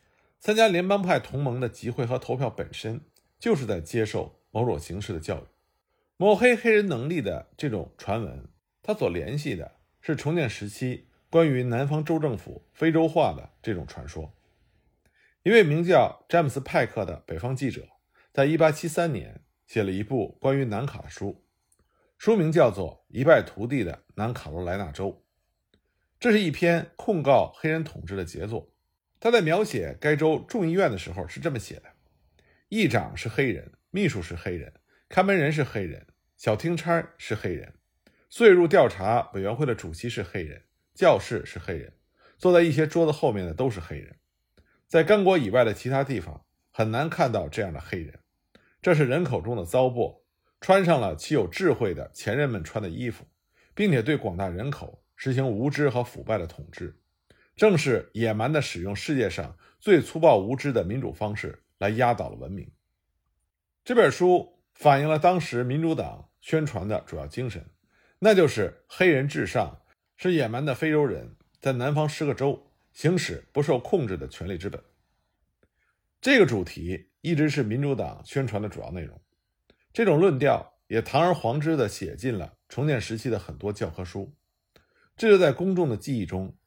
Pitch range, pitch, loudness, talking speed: 100-160 Hz, 130 Hz, -25 LUFS, 255 characters per minute